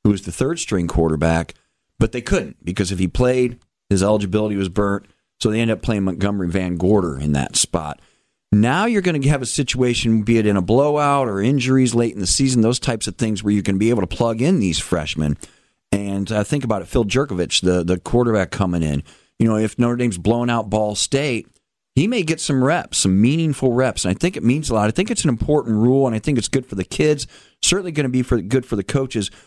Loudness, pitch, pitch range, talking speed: -19 LUFS, 110 Hz, 95-130 Hz, 240 wpm